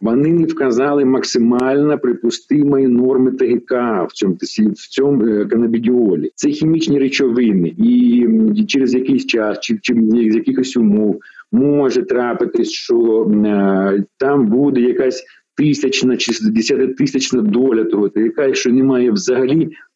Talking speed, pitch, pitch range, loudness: 125 wpm, 130 Hz, 115-145 Hz, -15 LUFS